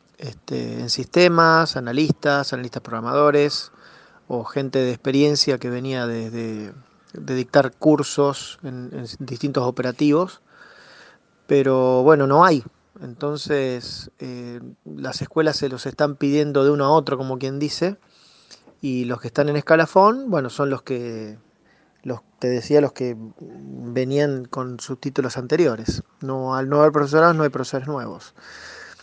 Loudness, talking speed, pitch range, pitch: -20 LUFS, 145 wpm, 125-145 Hz, 135 Hz